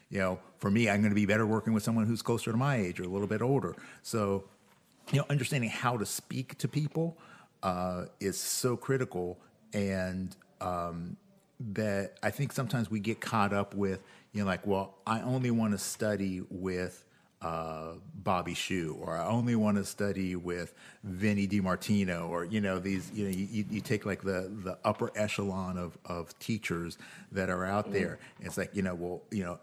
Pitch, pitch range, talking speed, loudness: 100 Hz, 90-110 Hz, 195 wpm, -33 LUFS